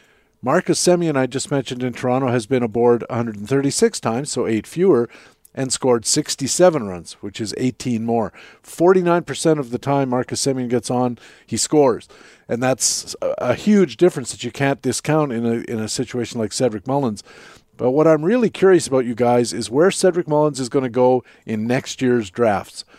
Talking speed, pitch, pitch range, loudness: 185 wpm, 130 Hz, 120-150 Hz, -19 LUFS